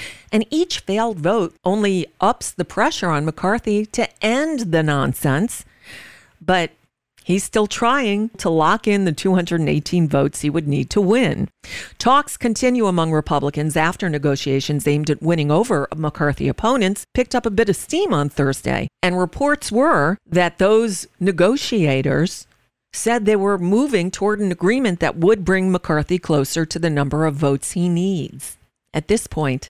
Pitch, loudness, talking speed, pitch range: 180 Hz, -19 LUFS, 155 wpm, 155-215 Hz